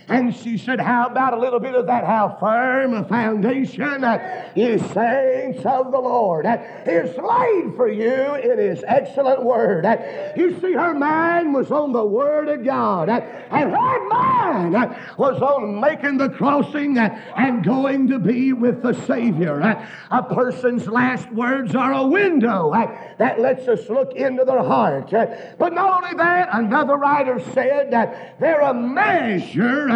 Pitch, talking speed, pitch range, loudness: 260 Hz, 180 wpm, 235-290 Hz, -19 LUFS